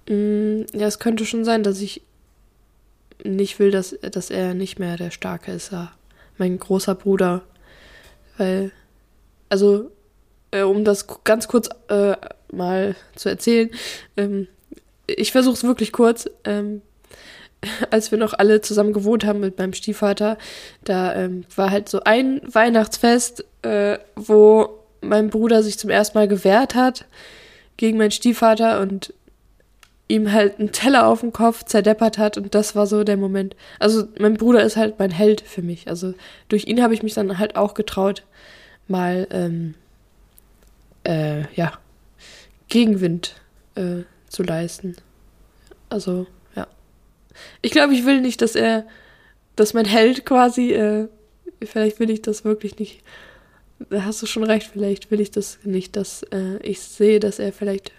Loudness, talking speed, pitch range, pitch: -19 LUFS, 150 wpm, 195-220 Hz, 210 Hz